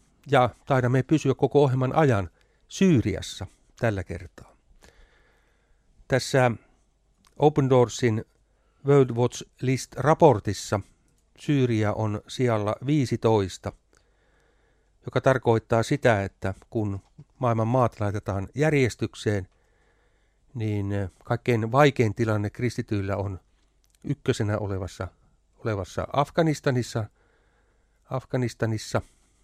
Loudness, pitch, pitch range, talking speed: -25 LUFS, 115 Hz, 105-135 Hz, 80 wpm